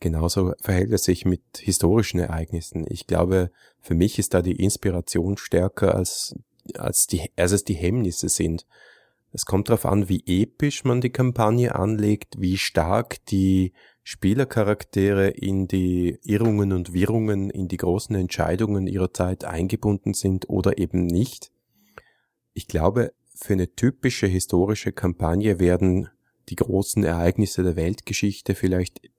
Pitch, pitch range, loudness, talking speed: 95 Hz, 90-105 Hz, -23 LUFS, 140 wpm